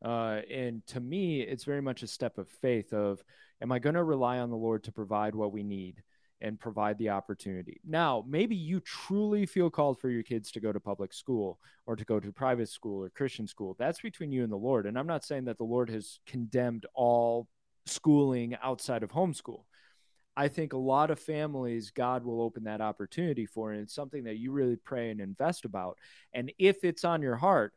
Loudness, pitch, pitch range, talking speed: -33 LUFS, 125 Hz, 110-145 Hz, 215 wpm